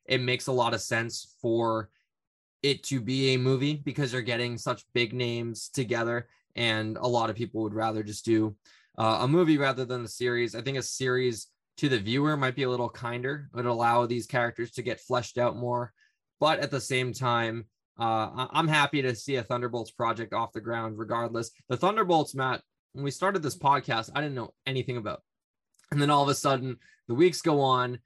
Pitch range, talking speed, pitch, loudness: 115-135 Hz, 205 wpm, 125 Hz, -28 LUFS